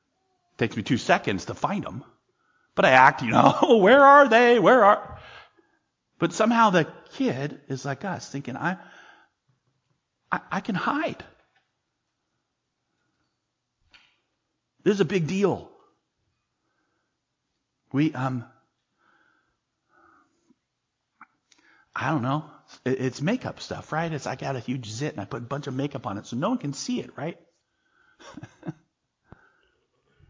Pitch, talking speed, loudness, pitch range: 150 Hz, 135 wpm, -23 LUFS, 135-195 Hz